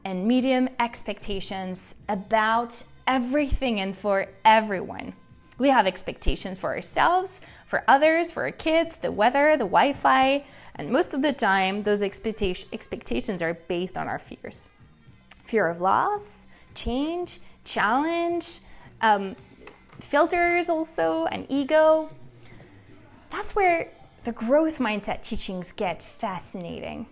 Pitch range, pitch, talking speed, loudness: 200-315 Hz, 240 Hz, 115 wpm, -24 LUFS